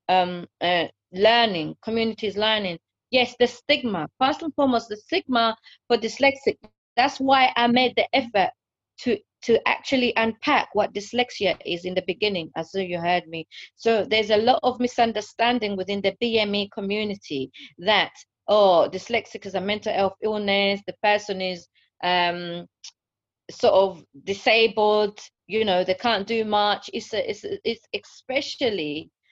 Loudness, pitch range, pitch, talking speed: -23 LUFS, 190-240 Hz, 210 Hz, 150 wpm